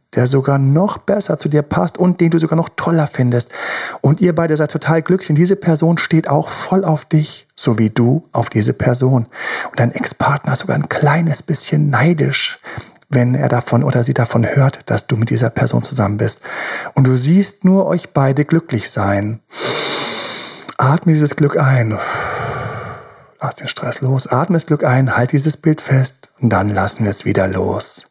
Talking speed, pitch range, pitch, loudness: 190 wpm, 125-160 Hz, 145 Hz, -15 LUFS